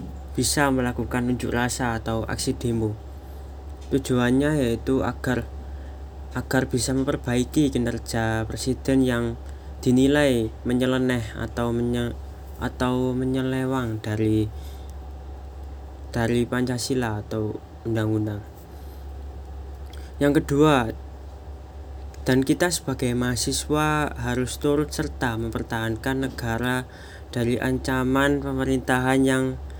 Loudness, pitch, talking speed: -24 LUFS, 120 Hz, 85 wpm